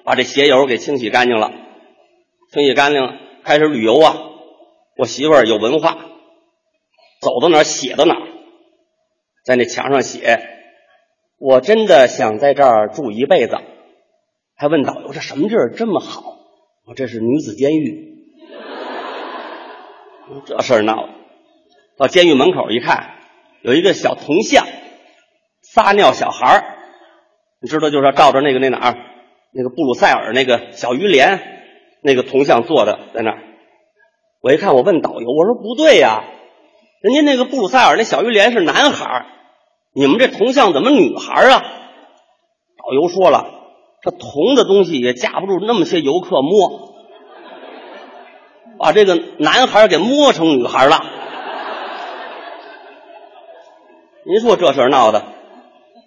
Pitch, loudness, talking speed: 315 Hz, -13 LUFS, 220 characters per minute